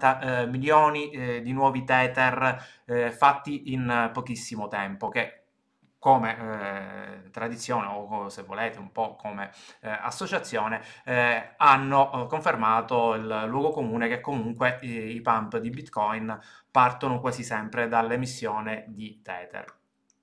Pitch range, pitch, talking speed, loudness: 110-130 Hz, 120 Hz, 105 wpm, -26 LUFS